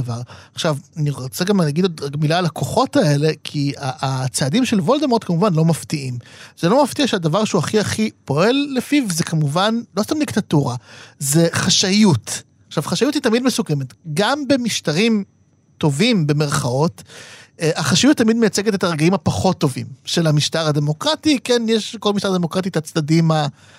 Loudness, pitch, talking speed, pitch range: -18 LUFS, 165 Hz, 155 wpm, 145-215 Hz